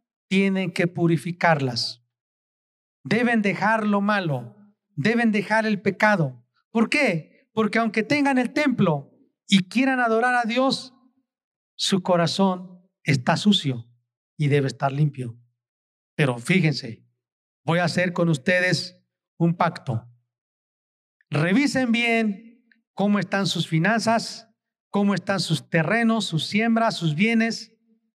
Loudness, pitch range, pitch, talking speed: -22 LUFS, 155-225 Hz, 195 Hz, 115 wpm